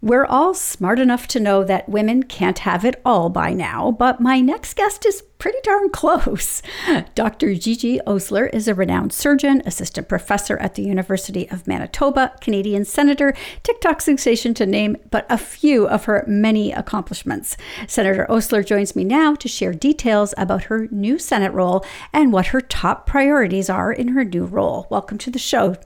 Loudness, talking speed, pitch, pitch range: -18 LUFS, 175 wpm, 230 Hz, 200-275 Hz